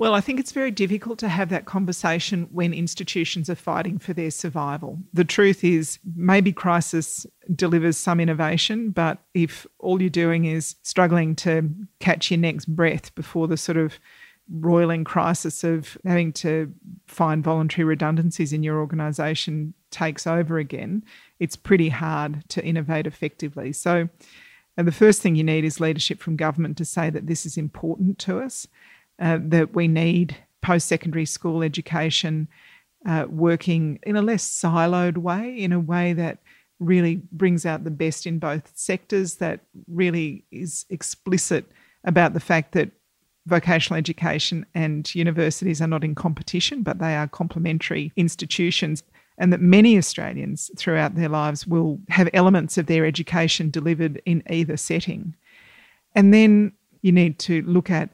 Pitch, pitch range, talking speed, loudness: 170 Hz, 160-180 Hz, 155 wpm, -22 LUFS